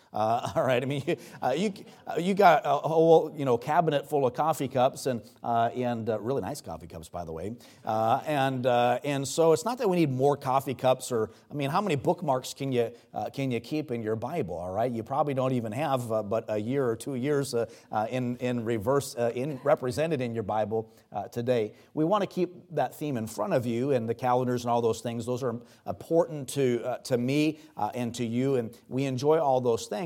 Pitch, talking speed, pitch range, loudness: 130 Hz, 240 wpm, 115-145 Hz, -28 LUFS